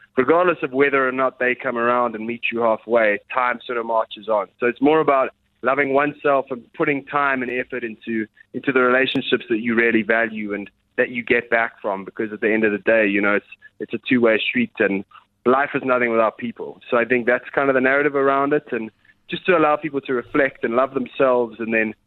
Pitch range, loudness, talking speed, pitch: 115-140 Hz, -20 LUFS, 230 wpm, 125 Hz